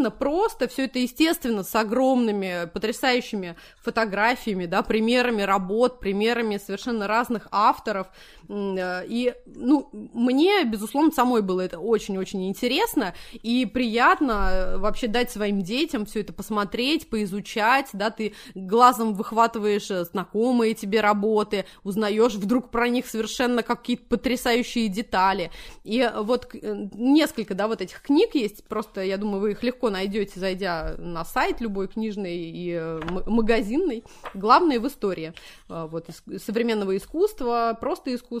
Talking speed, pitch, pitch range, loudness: 125 wpm, 225 Hz, 200-245 Hz, -24 LUFS